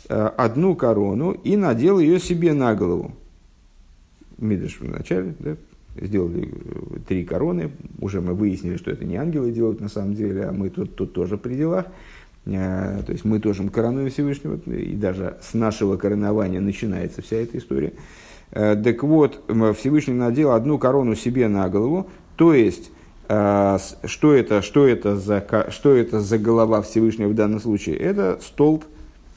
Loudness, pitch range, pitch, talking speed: -21 LUFS, 100-130 Hz, 110 Hz, 150 wpm